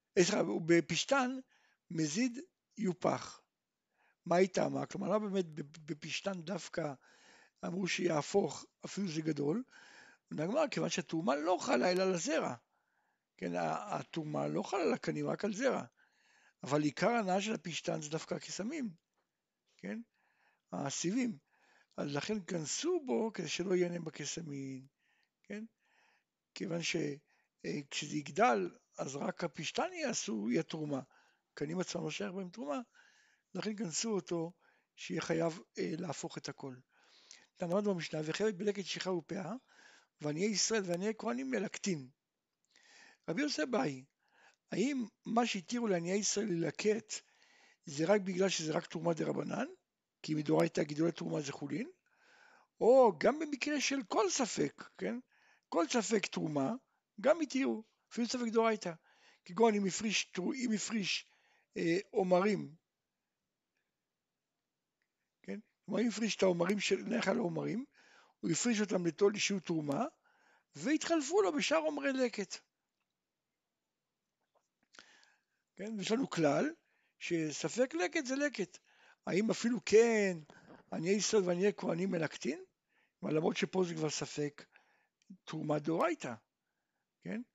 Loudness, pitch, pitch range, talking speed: -36 LUFS, 200 Hz, 170-245 Hz, 125 wpm